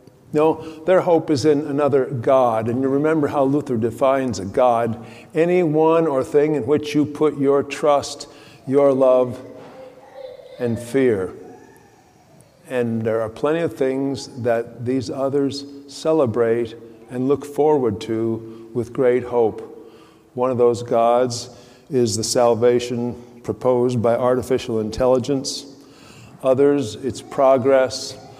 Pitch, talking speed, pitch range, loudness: 130 Hz, 125 wpm, 120-145 Hz, -19 LUFS